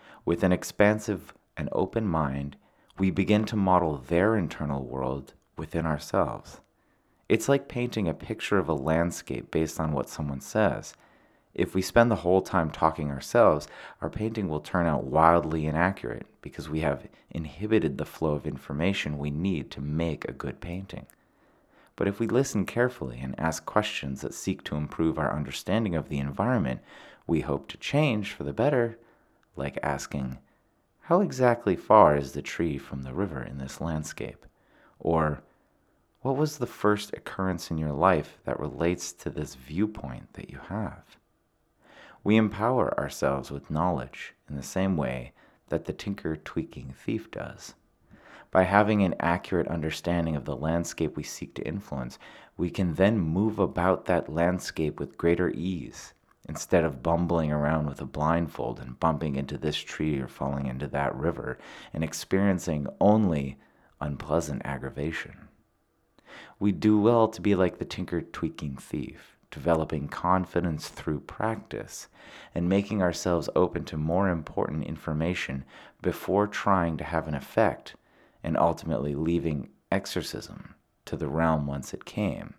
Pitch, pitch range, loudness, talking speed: 80 Hz, 75-95 Hz, -28 LUFS, 155 wpm